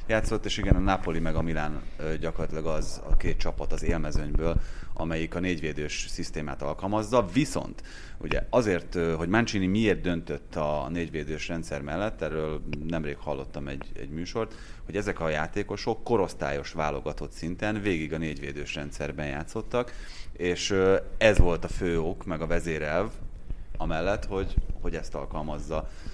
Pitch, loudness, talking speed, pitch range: 80 Hz, -30 LUFS, 145 wpm, 75-95 Hz